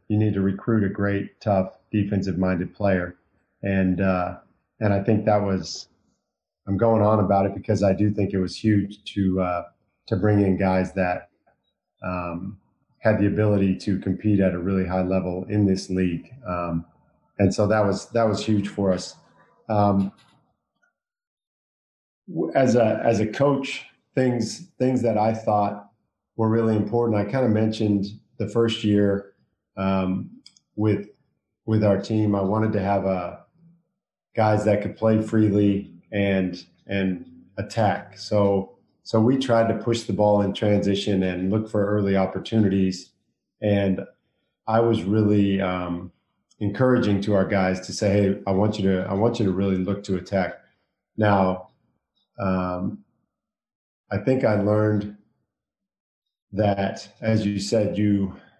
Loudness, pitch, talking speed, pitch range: -23 LUFS, 100 Hz, 155 wpm, 95-110 Hz